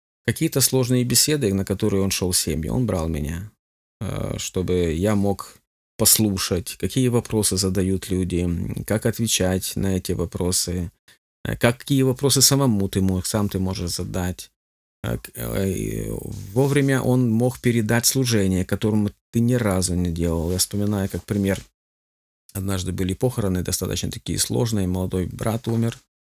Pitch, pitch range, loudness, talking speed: 100 Hz, 90-115 Hz, -22 LUFS, 130 wpm